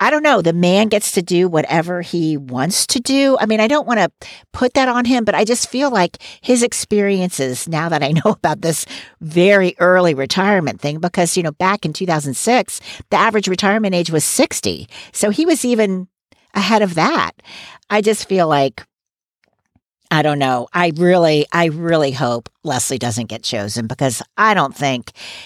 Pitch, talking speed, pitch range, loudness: 180 Hz, 185 wpm, 150-210 Hz, -16 LUFS